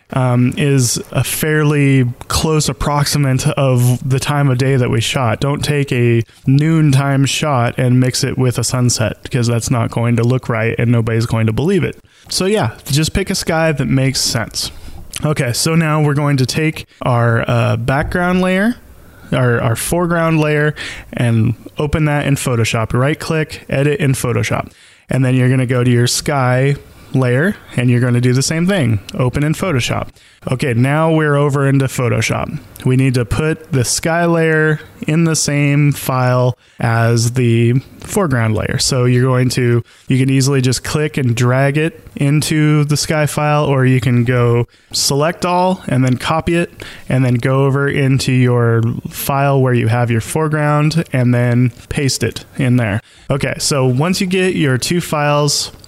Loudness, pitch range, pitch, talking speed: -15 LUFS, 120-150 Hz, 130 Hz, 180 wpm